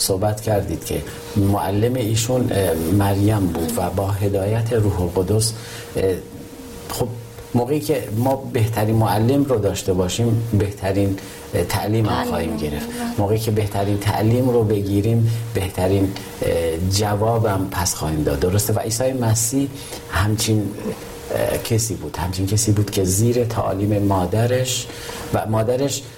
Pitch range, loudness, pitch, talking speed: 95-115 Hz, -20 LUFS, 105 Hz, 120 wpm